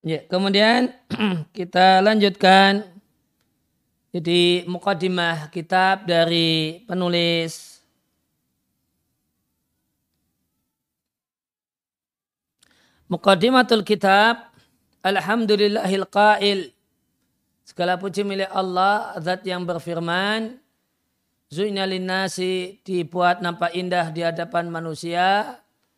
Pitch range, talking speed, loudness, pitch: 170-200 Hz, 60 wpm, -20 LUFS, 185 Hz